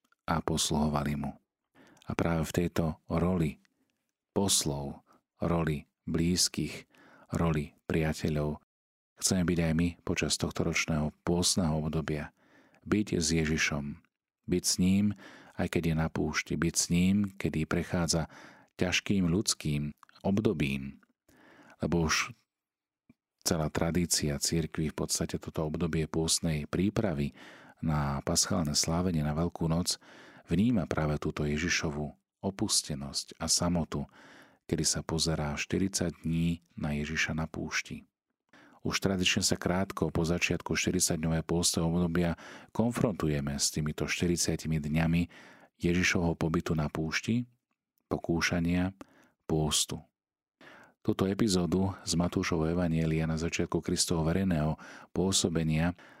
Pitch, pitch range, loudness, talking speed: 80 Hz, 75-90 Hz, -30 LUFS, 110 wpm